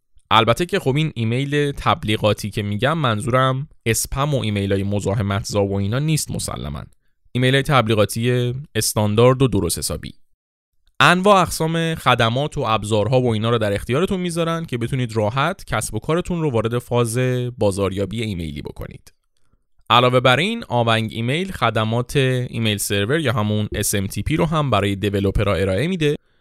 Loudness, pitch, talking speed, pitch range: -19 LUFS, 120 Hz, 150 wpm, 105-140 Hz